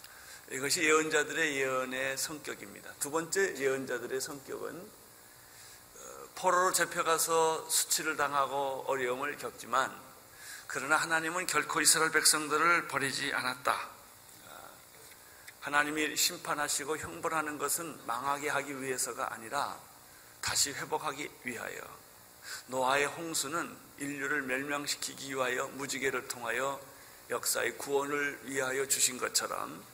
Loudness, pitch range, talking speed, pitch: -31 LUFS, 125-155 Hz, 290 characters per minute, 140 Hz